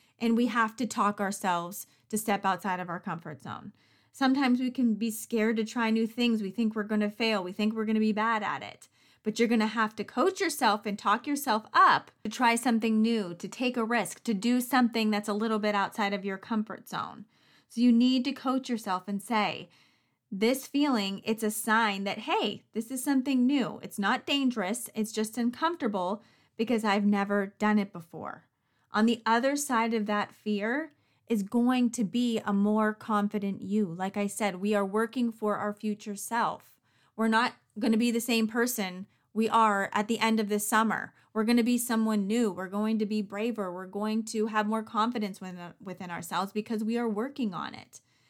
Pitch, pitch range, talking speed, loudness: 220 Hz, 205-235 Hz, 205 wpm, -29 LUFS